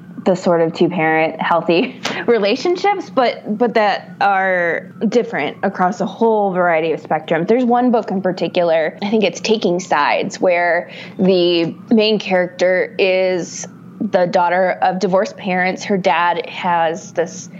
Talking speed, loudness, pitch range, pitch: 145 wpm, -16 LUFS, 175-205 Hz, 185 Hz